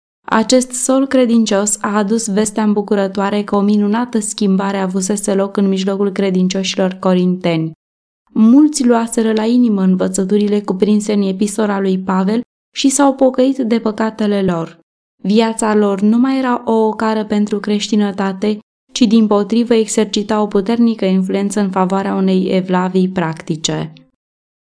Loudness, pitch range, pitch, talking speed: -15 LUFS, 195-225 Hz, 210 Hz, 130 wpm